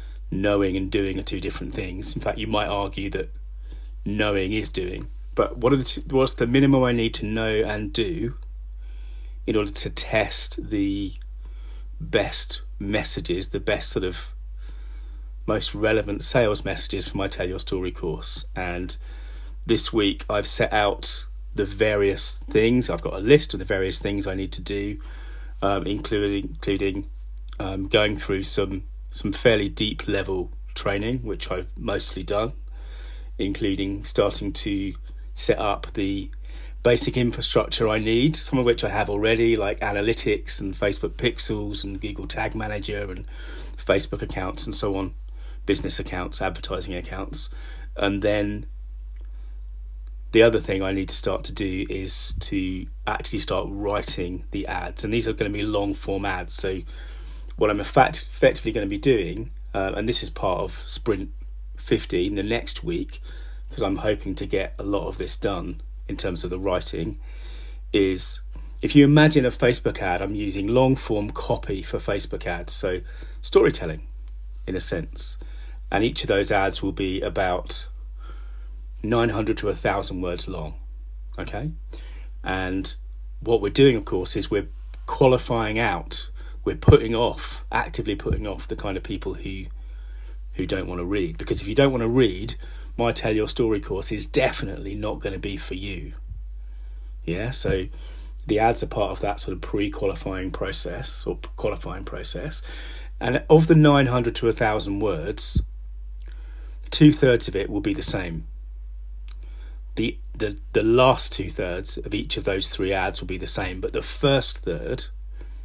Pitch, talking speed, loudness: 95 Hz, 160 wpm, -24 LUFS